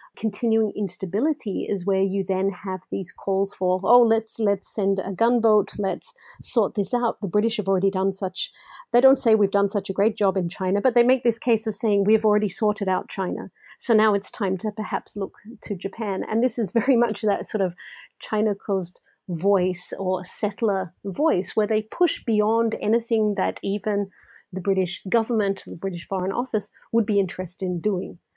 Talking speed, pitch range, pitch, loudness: 190 wpm, 195-225 Hz, 205 Hz, -24 LUFS